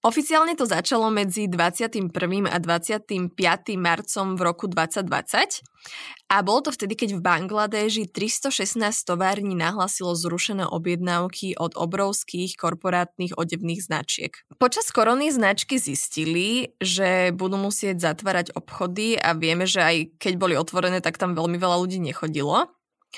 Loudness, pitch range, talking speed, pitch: -23 LUFS, 175-210 Hz, 130 wpm, 185 Hz